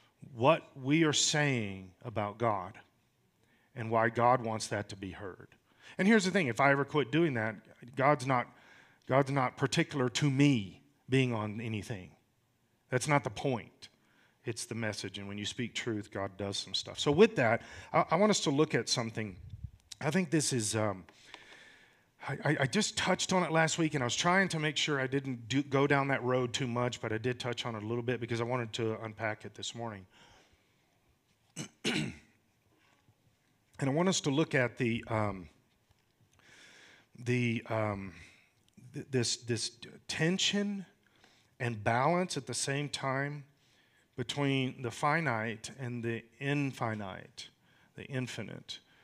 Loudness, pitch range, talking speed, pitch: -32 LUFS, 110-145 Hz, 165 wpm, 125 Hz